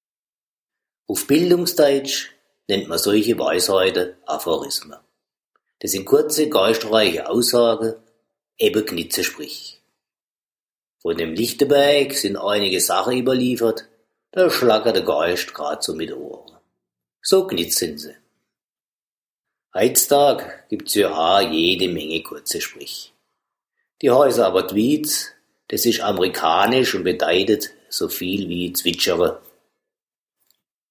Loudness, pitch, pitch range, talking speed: -19 LUFS, 125 Hz, 110-150 Hz, 105 wpm